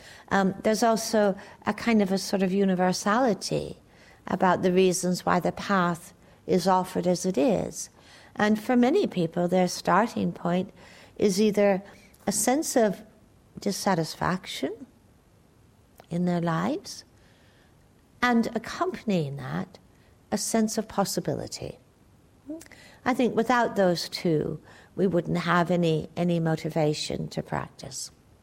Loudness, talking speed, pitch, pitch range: -26 LUFS, 120 wpm, 185 Hz, 170-210 Hz